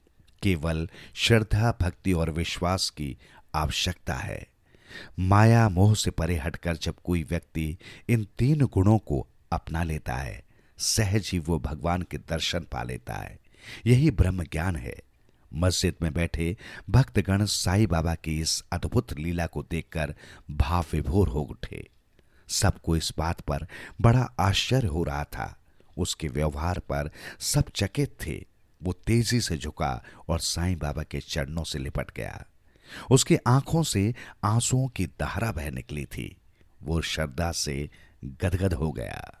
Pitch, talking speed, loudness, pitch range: 85 Hz, 140 wpm, -27 LUFS, 80-100 Hz